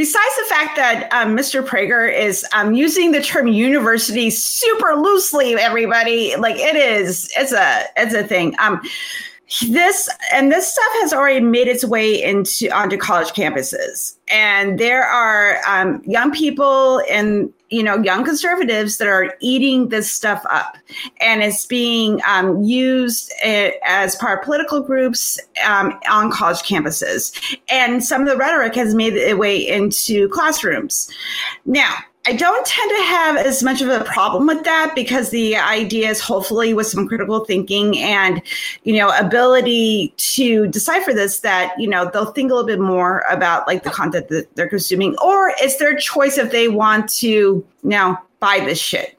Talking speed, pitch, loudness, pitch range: 170 wpm, 235 Hz, -15 LUFS, 205-280 Hz